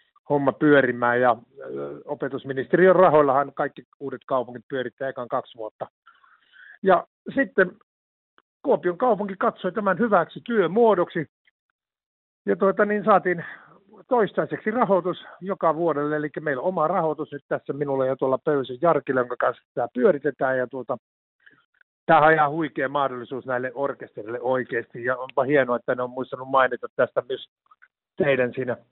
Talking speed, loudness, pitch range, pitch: 135 wpm, -23 LUFS, 130-185 Hz, 145 Hz